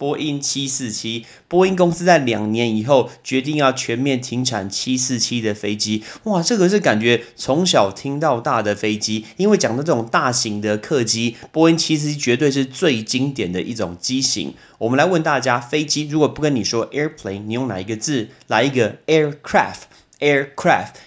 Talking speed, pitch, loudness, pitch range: 350 characters per minute, 130 Hz, -18 LUFS, 110-150 Hz